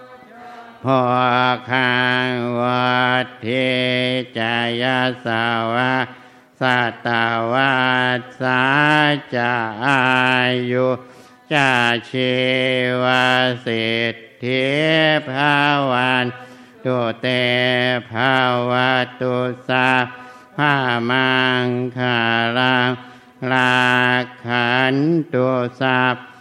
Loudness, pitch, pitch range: -17 LUFS, 125 Hz, 125-130 Hz